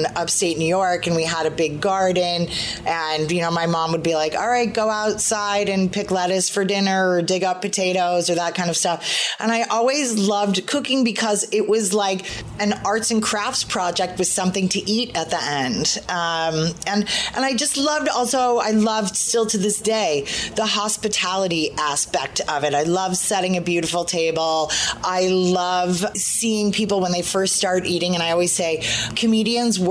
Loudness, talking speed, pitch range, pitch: -20 LUFS, 190 wpm, 175-215 Hz, 190 Hz